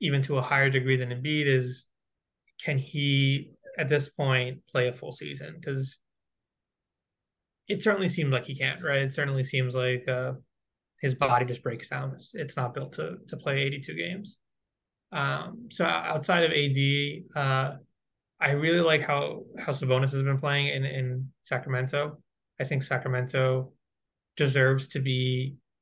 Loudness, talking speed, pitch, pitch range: -28 LUFS, 160 wpm, 135 Hz, 130-145 Hz